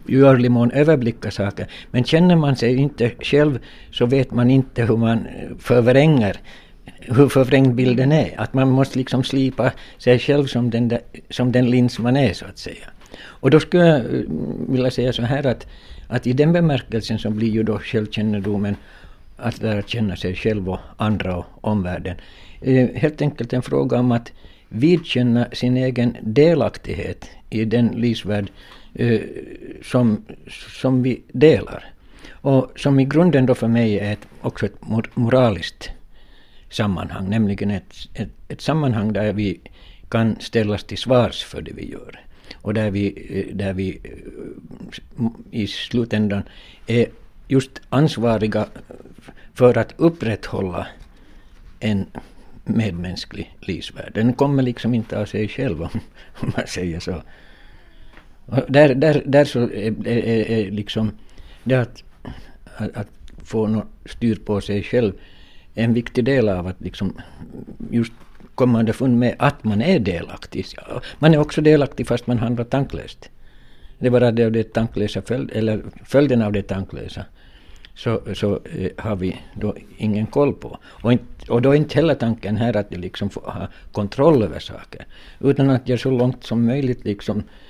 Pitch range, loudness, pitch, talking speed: 105-130 Hz, -19 LUFS, 115 Hz, 155 wpm